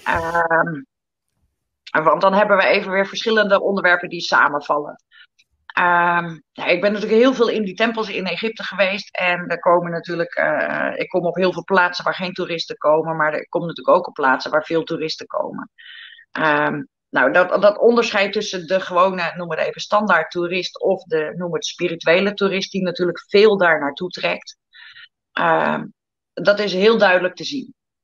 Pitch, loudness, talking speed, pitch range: 180 Hz, -18 LUFS, 175 wpm, 170-205 Hz